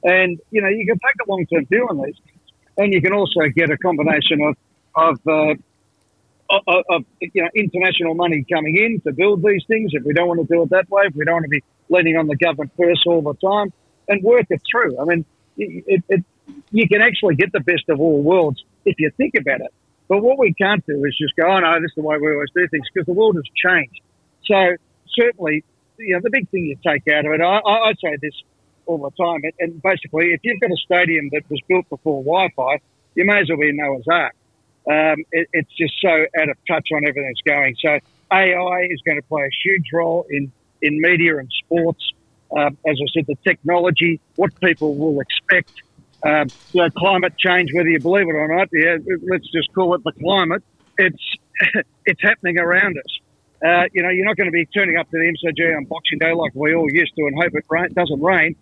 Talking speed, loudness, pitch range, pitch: 230 wpm, -17 LUFS, 150-185 Hz, 165 Hz